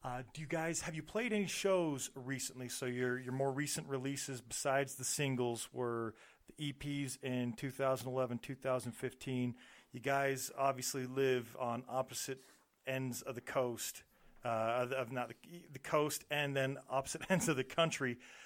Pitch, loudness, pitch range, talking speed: 130 Hz, -39 LUFS, 125-140 Hz, 155 wpm